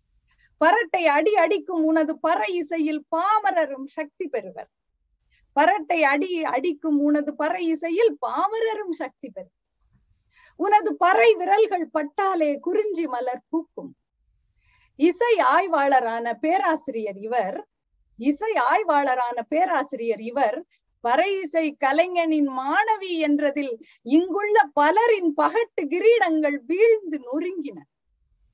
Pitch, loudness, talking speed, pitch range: 325 Hz, -22 LUFS, 95 wpm, 290-375 Hz